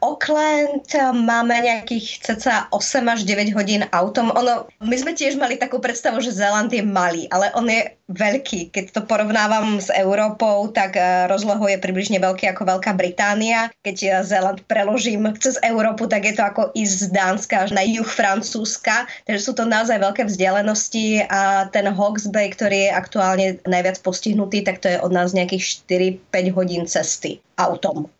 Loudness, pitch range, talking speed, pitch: -19 LUFS, 190-230 Hz, 170 wpm, 210 Hz